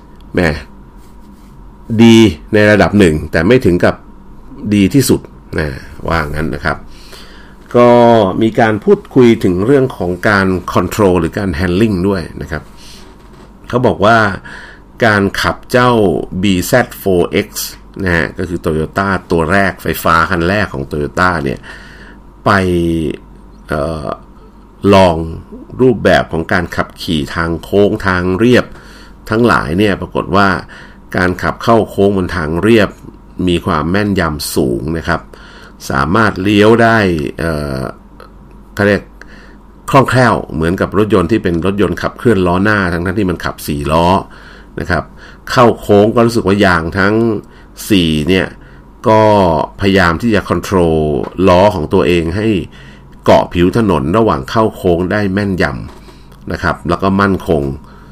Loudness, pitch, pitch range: -12 LUFS, 95 Hz, 80-105 Hz